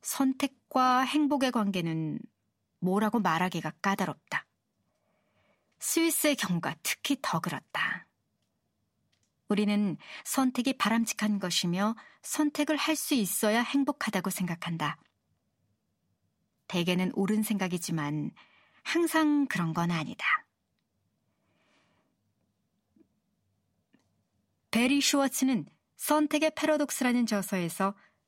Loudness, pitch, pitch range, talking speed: -29 LUFS, 215 Hz, 180-280 Hz, 210 characters per minute